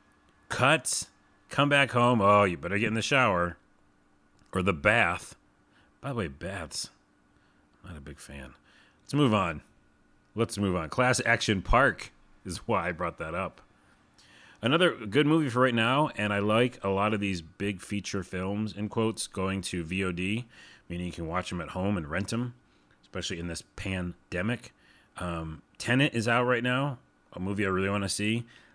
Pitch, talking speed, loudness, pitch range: 100 Hz, 175 wpm, -28 LUFS, 90-115 Hz